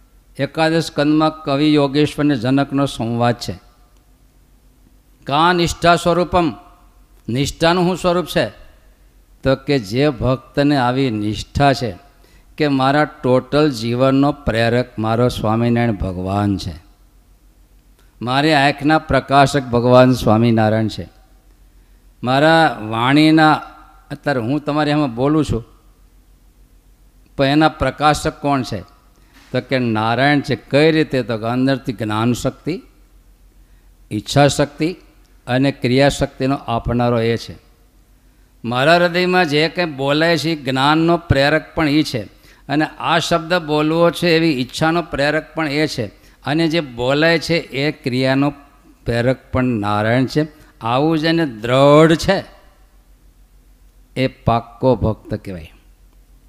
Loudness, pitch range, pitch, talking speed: -16 LUFS, 115-150 Hz, 135 Hz, 115 wpm